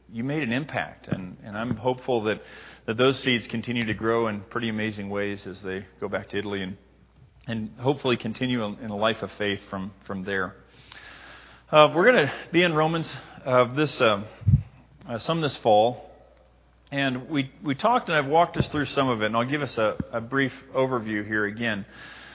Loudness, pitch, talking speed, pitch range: -25 LUFS, 115 Hz, 205 wpm, 105-135 Hz